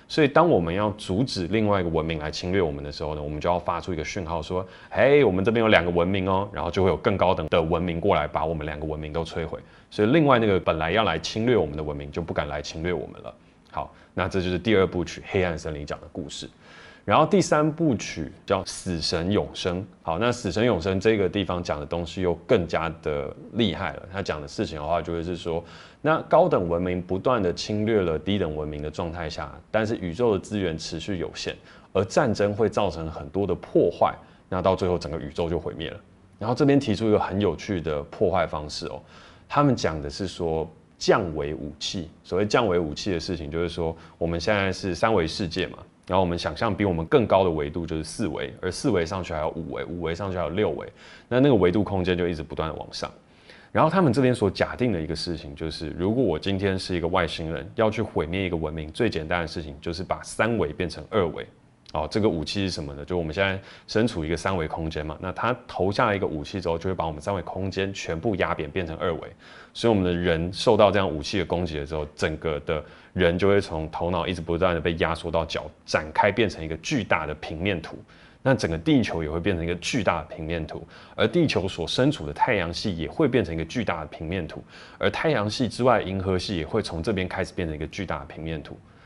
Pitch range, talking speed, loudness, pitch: 80-100 Hz, 350 characters per minute, -25 LUFS, 90 Hz